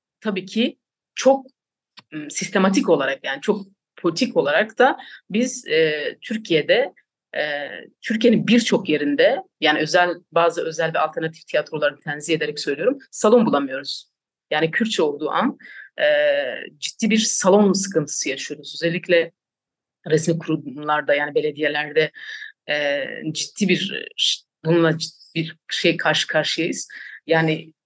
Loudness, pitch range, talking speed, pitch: -21 LUFS, 155-225 Hz, 115 wpm, 170 Hz